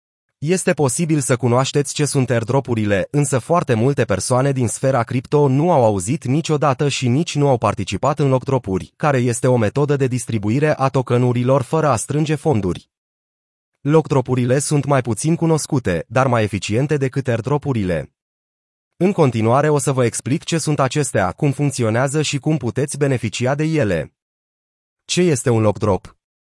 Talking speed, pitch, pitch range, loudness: 155 wpm, 135 Hz, 120-145 Hz, -18 LUFS